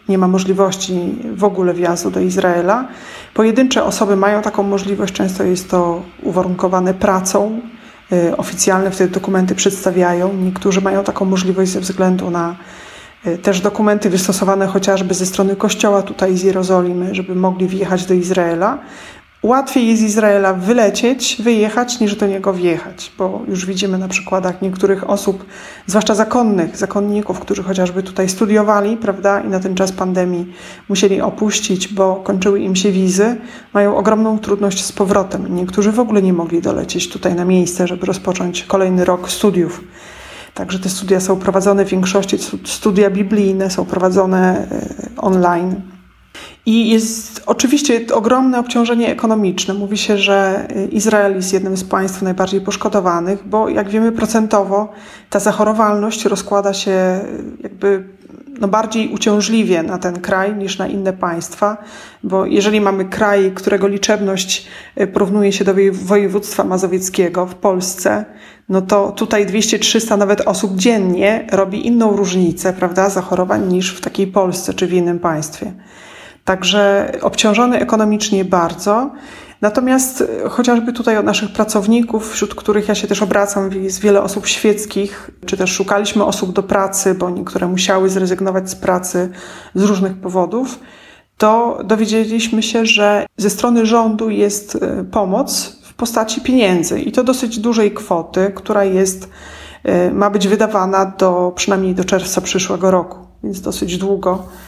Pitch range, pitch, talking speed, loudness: 185-210 Hz, 195 Hz, 140 wpm, -15 LUFS